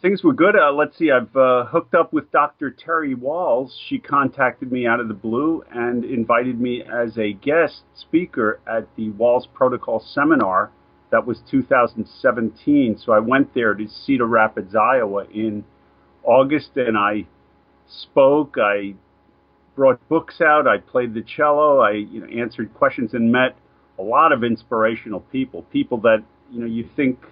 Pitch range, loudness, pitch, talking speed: 110-140 Hz, -19 LUFS, 120 Hz, 165 wpm